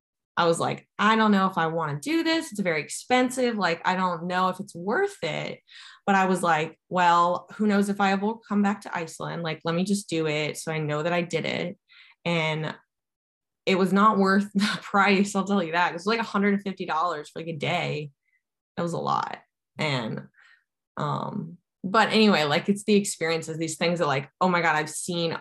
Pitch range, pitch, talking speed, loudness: 165-205 Hz, 185 Hz, 215 wpm, -25 LUFS